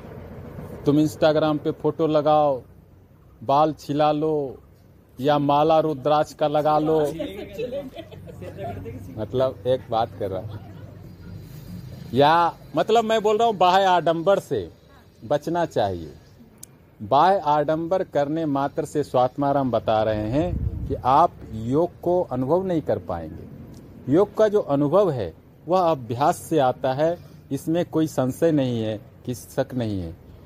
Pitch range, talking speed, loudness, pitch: 110-160 Hz, 130 wpm, -22 LUFS, 140 Hz